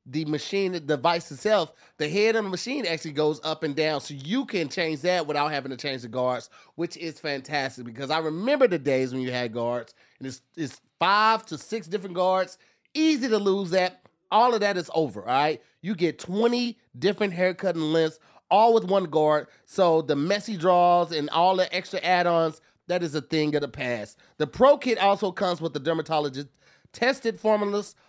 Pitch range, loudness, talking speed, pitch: 150-200 Hz, -25 LUFS, 200 wpm, 170 Hz